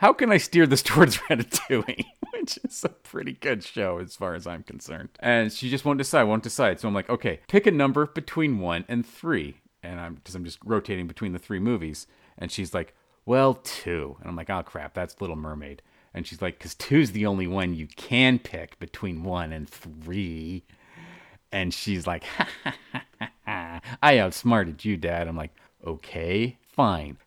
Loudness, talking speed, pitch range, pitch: -25 LUFS, 200 wpm, 85-120 Hz, 95 Hz